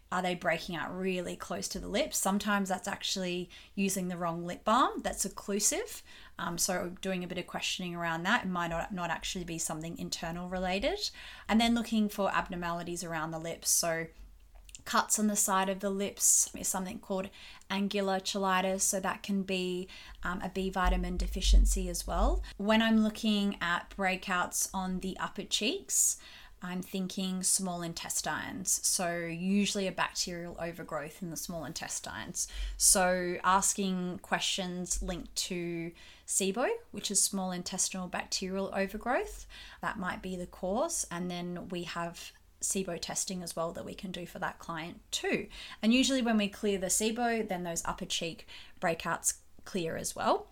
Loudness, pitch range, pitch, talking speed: -32 LUFS, 175-200 Hz, 185 Hz, 165 wpm